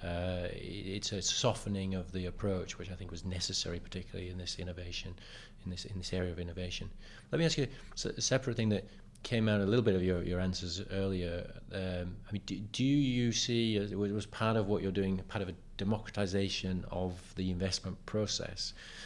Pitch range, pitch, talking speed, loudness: 90-105 Hz, 95 Hz, 205 wpm, -35 LUFS